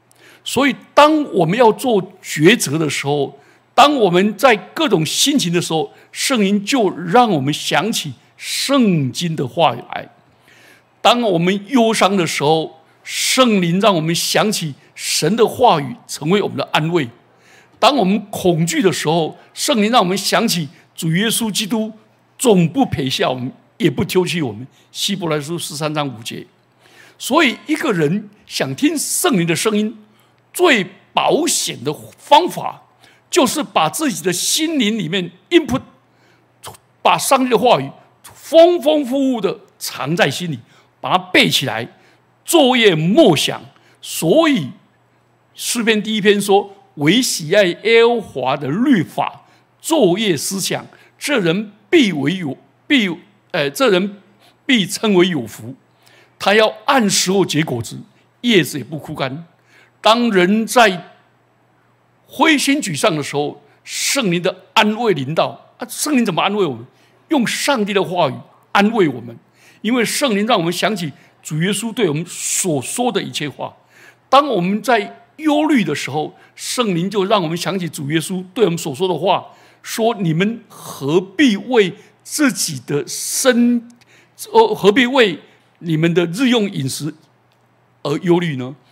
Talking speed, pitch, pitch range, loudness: 215 characters per minute, 195 Hz, 160-235 Hz, -16 LUFS